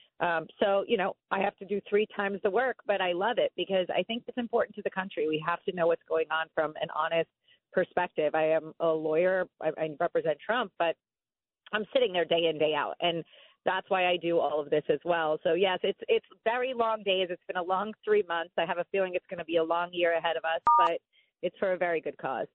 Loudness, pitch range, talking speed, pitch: -29 LUFS, 165-200 Hz, 255 wpm, 180 Hz